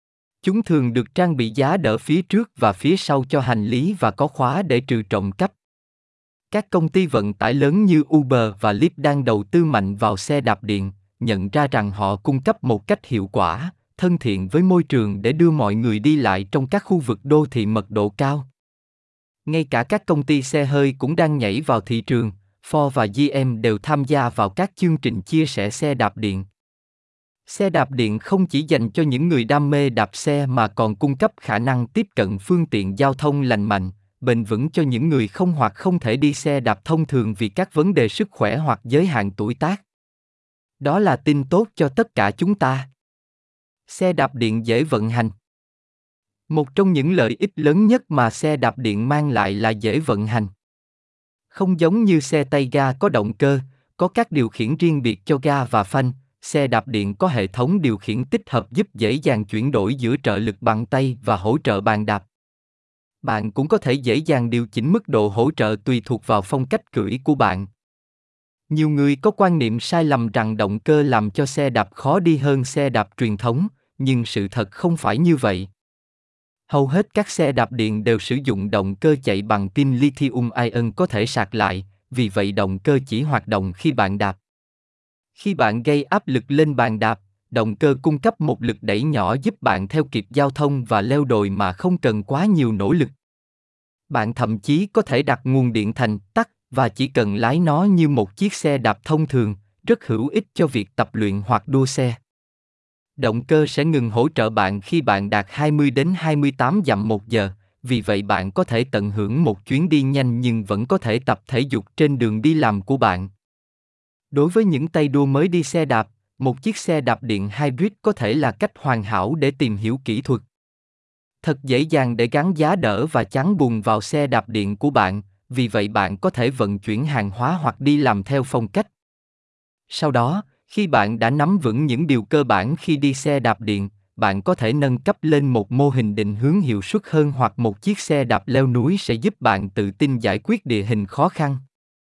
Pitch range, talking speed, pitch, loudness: 110-150 Hz, 215 wpm, 130 Hz, -20 LUFS